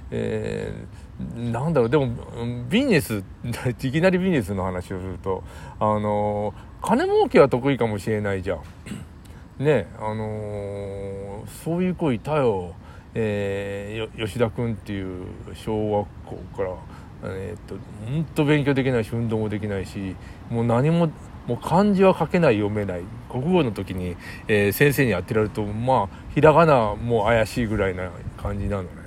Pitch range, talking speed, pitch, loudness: 100-130 Hz, 295 characters per minute, 110 Hz, -23 LUFS